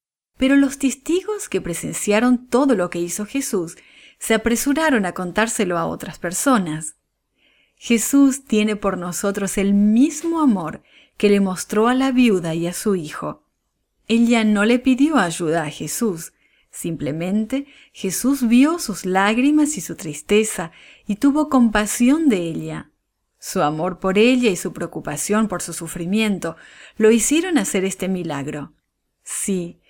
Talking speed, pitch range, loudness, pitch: 140 wpm, 180-255 Hz, -19 LUFS, 210 Hz